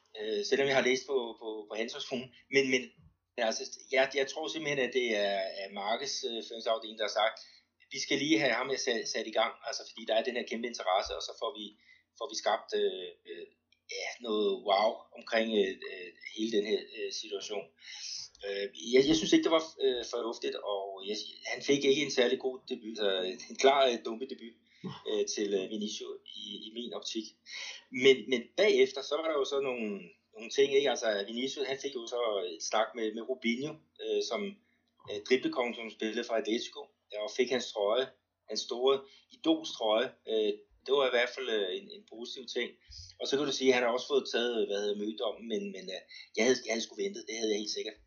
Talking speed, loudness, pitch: 210 wpm, -32 LUFS, 175 Hz